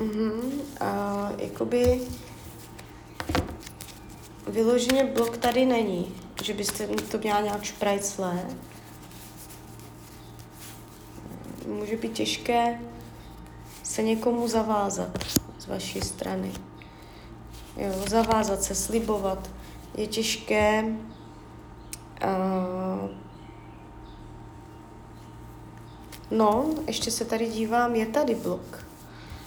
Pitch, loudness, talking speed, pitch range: 220 Hz, -27 LUFS, 80 wpm, 195-235 Hz